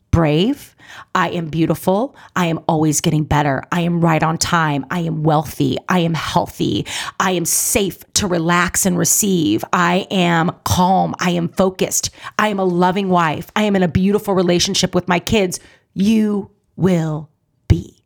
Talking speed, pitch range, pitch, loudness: 165 wpm, 160-190 Hz, 175 Hz, -17 LUFS